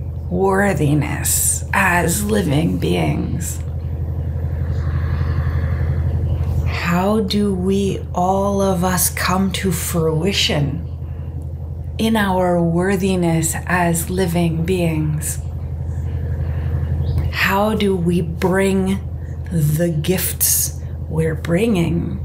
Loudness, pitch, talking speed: -18 LUFS, 85 Hz, 75 wpm